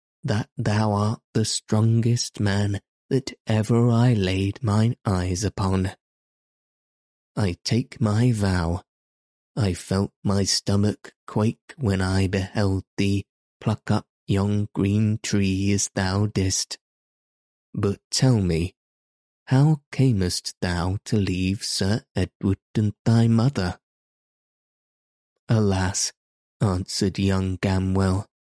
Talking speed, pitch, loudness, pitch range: 105 wpm, 100 Hz, -24 LUFS, 95-110 Hz